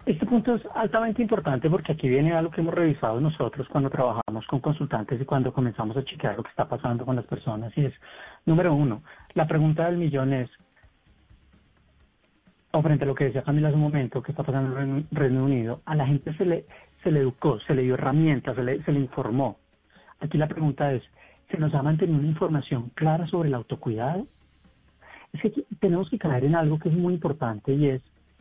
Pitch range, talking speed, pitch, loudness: 130-165 Hz, 210 wpm, 145 Hz, -26 LUFS